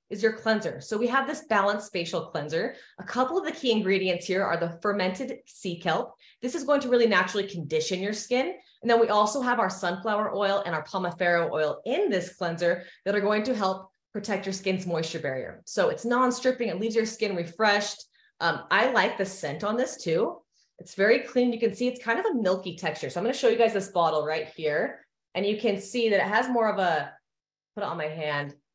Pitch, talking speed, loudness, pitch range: 205 Hz, 230 wpm, -27 LUFS, 175-235 Hz